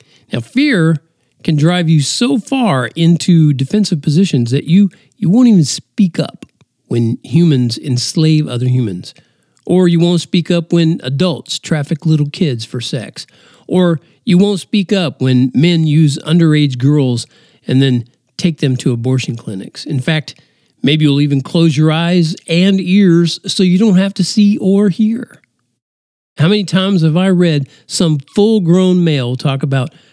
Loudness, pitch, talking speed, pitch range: -13 LUFS, 165 Hz, 160 wpm, 140-180 Hz